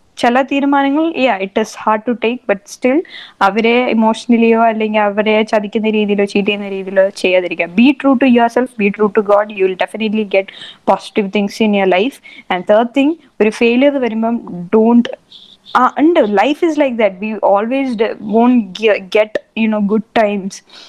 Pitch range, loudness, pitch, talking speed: 205-245 Hz, -14 LUFS, 220 Hz, 160 wpm